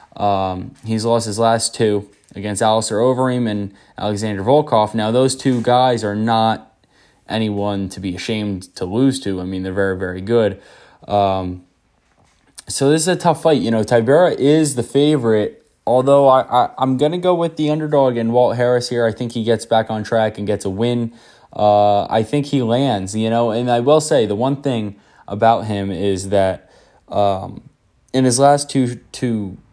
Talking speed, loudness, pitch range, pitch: 190 wpm, -17 LUFS, 100-130 Hz, 115 Hz